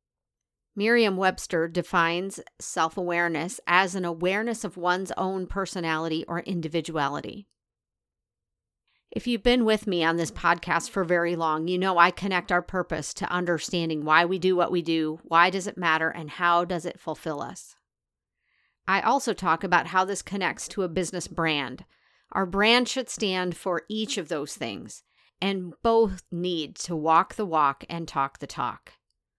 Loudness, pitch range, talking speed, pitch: -26 LUFS, 165-190 Hz, 160 wpm, 175 Hz